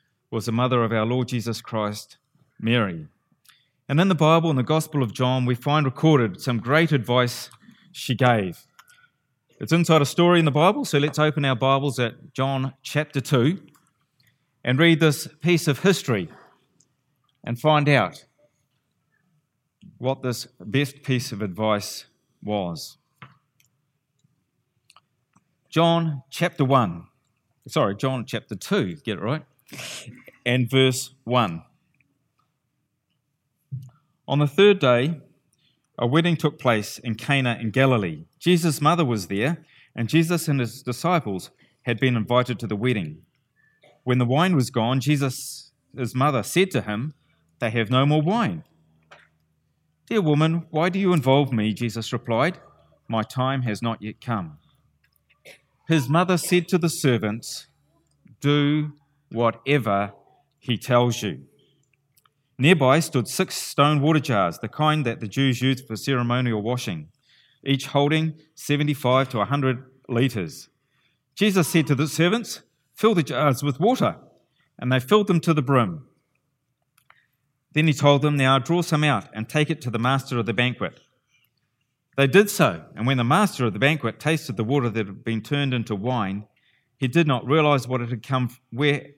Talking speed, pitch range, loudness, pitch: 150 wpm, 120-150 Hz, -22 LUFS, 135 Hz